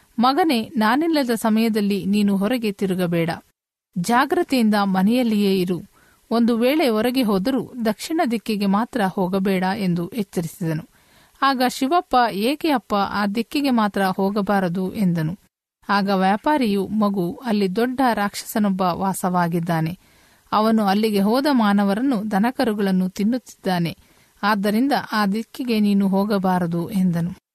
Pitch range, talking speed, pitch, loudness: 190-235 Hz, 100 wpm, 205 Hz, -20 LUFS